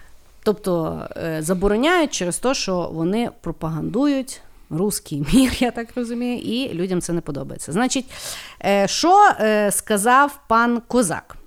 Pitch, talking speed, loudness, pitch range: 215 Hz, 115 wpm, -20 LUFS, 180-250 Hz